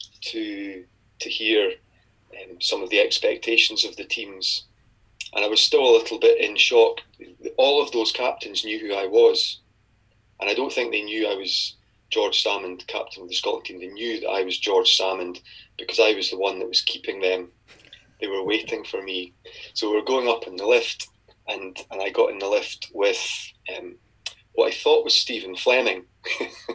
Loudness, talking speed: -22 LUFS, 195 wpm